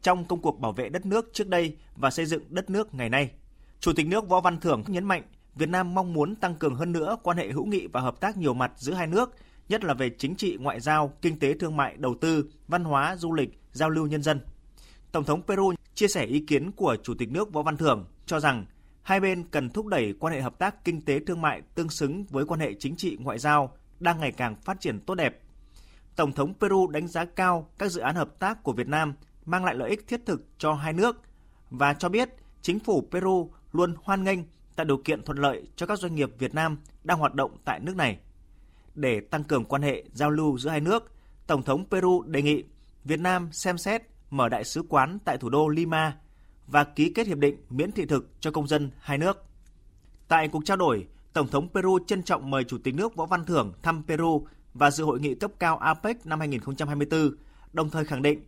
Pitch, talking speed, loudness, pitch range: 155 Hz, 235 wpm, -27 LUFS, 140-180 Hz